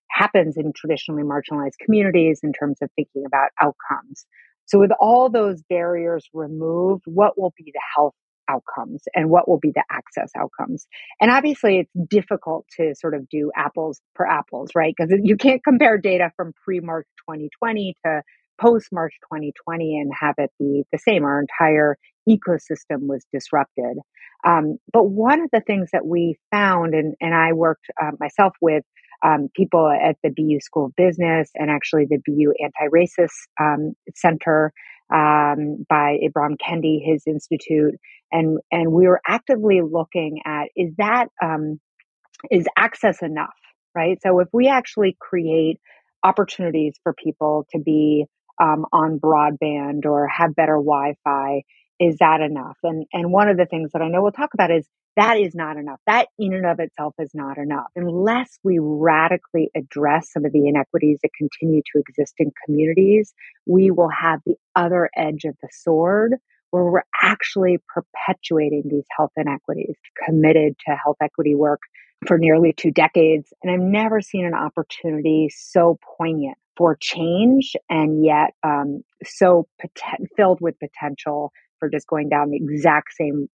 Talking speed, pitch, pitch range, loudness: 165 wpm, 160 Hz, 150-180 Hz, -19 LUFS